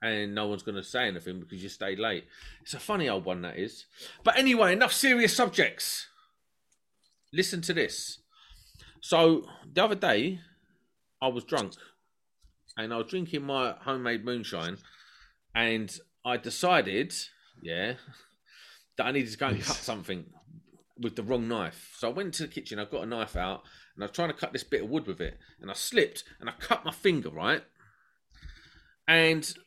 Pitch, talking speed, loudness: 140 Hz, 180 wpm, -29 LUFS